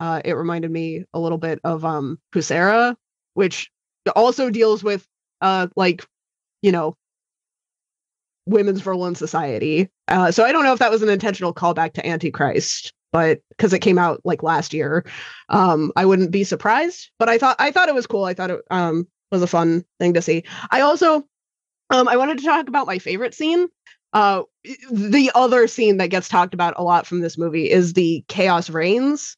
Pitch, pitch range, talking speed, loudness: 185 Hz, 170-235 Hz, 190 wpm, -19 LUFS